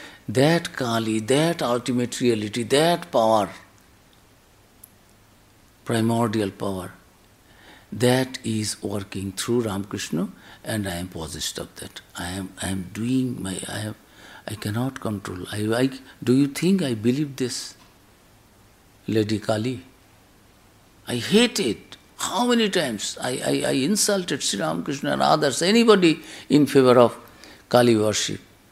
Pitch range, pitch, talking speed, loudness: 100-130 Hz, 110 Hz, 125 wpm, -23 LUFS